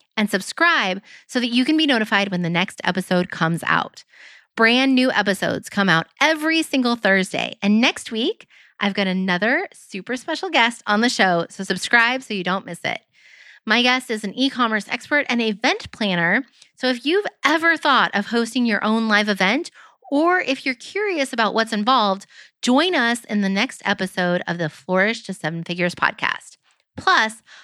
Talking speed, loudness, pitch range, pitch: 180 wpm, -19 LUFS, 195-265 Hz, 225 Hz